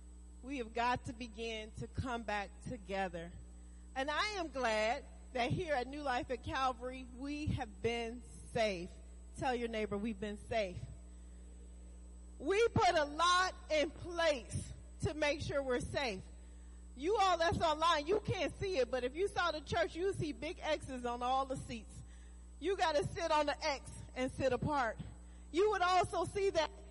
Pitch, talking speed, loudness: 255 Hz, 175 wpm, -37 LUFS